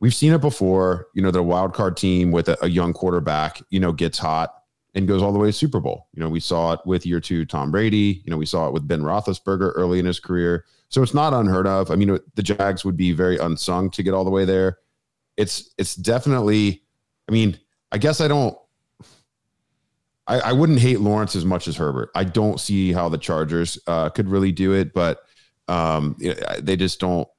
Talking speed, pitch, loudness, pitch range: 225 wpm, 95 Hz, -21 LUFS, 85-105 Hz